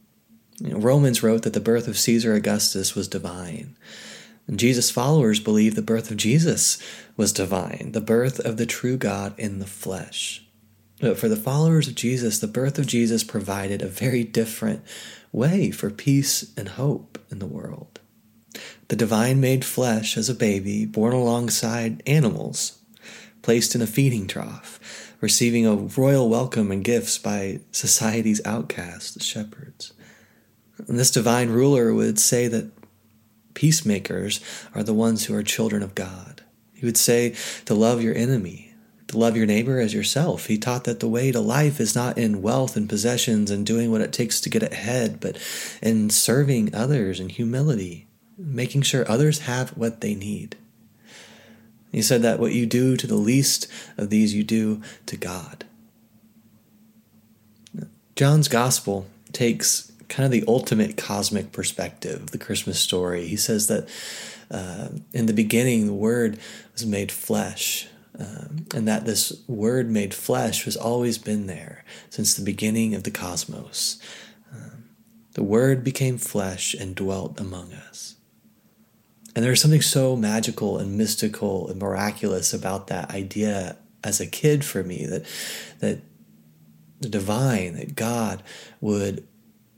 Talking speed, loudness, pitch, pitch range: 155 wpm, -22 LUFS, 115 Hz, 105-125 Hz